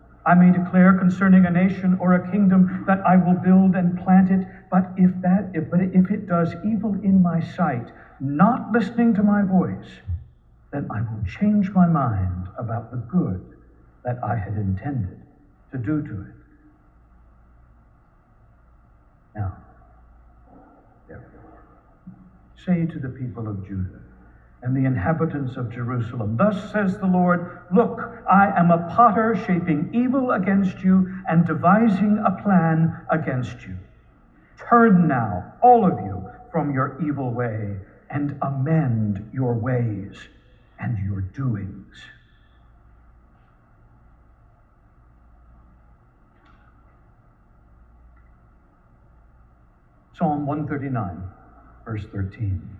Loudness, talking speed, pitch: -21 LUFS, 115 wpm, 145 Hz